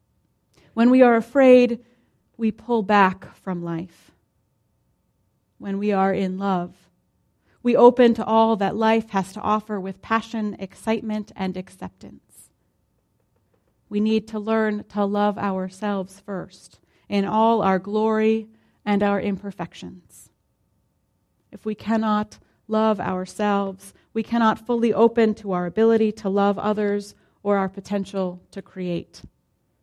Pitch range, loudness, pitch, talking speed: 195-220 Hz, -22 LUFS, 205 Hz, 125 wpm